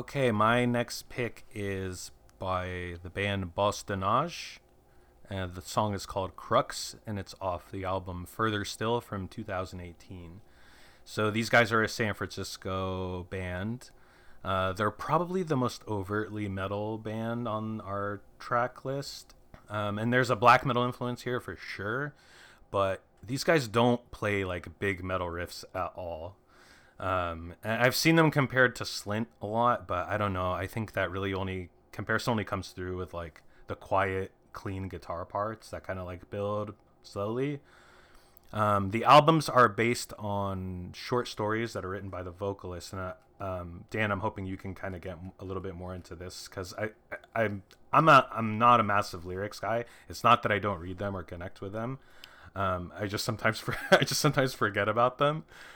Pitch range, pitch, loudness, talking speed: 95-115 Hz, 100 Hz, -30 LUFS, 180 wpm